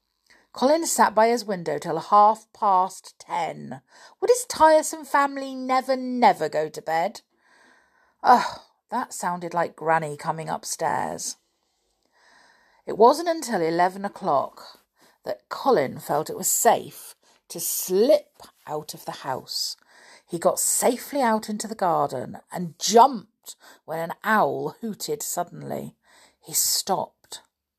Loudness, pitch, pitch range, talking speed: -23 LUFS, 210 Hz, 165-265 Hz, 125 wpm